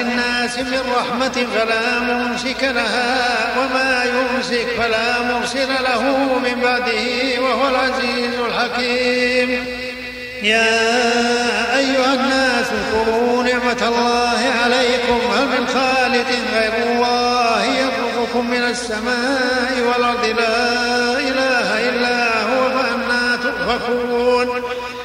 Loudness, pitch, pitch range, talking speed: -17 LUFS, 245 Hz, 240-250 Hz, 90 wpm